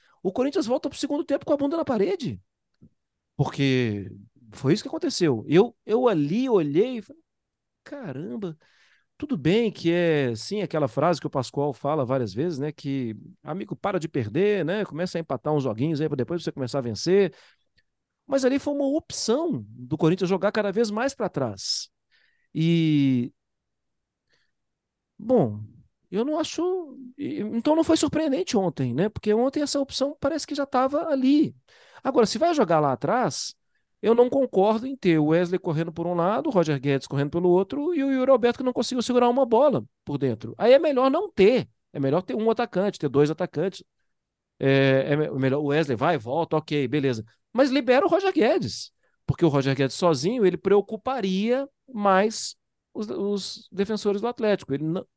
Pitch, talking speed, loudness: 190 Hz, 180 wpm, -24 LUFS